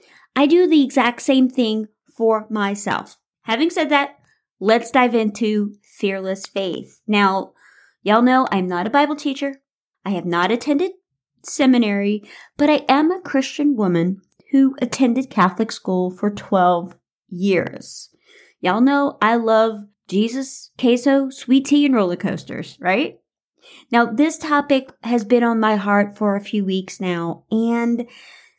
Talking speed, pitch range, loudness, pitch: 145 wpm, 200-275 Hz, -19 LUFS, 230 Hz